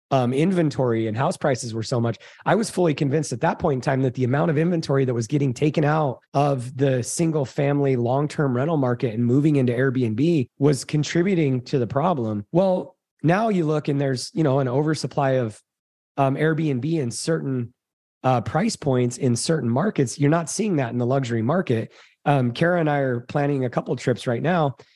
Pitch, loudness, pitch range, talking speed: 140 Hz, -22 LUFS, 125-155 Hz, 200 wpm